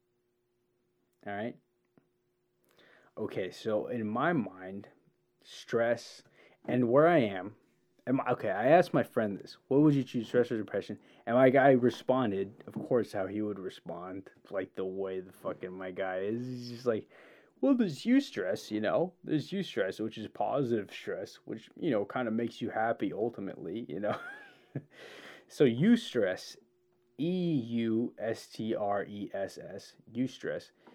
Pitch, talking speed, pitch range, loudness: 120 Hz, 165 wpm, 100-135 Hz, -32 LUFS